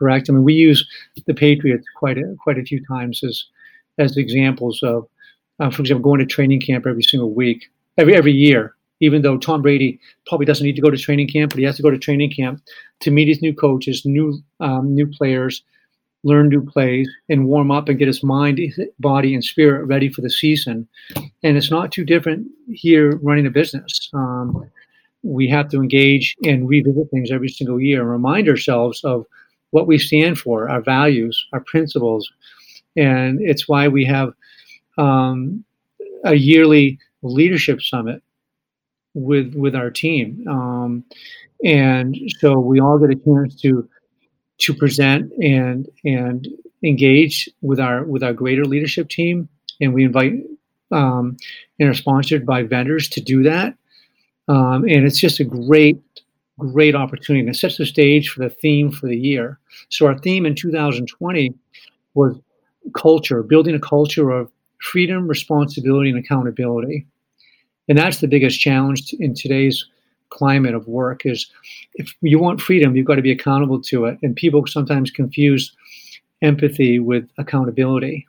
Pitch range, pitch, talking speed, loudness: 130-150 Hz, 140 Hz, 170 wpm, -16 LUFS